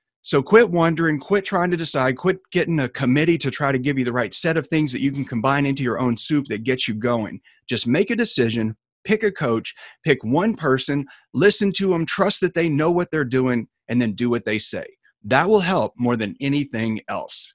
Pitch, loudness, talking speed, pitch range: 140 Hz, -21 LUFS, 225 wpm, 120-175 Hz